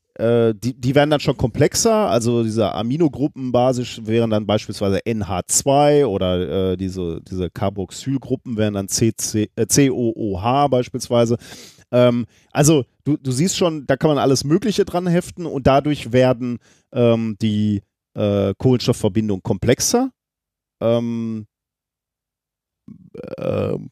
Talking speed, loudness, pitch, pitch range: 120 wpm, -19 LUFS, 120 Hz, 105-135 Hz